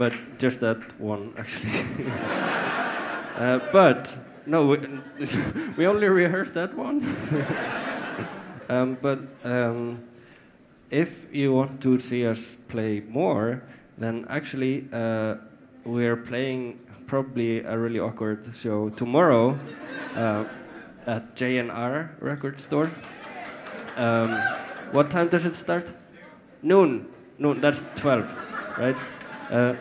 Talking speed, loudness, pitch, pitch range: 110 wpm, -26 LUFS, 125 Hz, 115-140 Hz